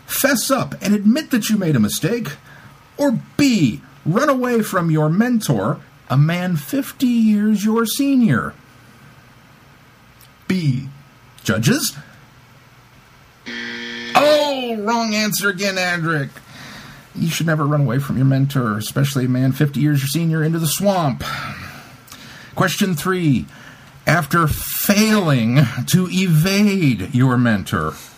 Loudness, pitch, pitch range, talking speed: -18 LUFS, 160 Hz, 135-210 Hz, 115 wpm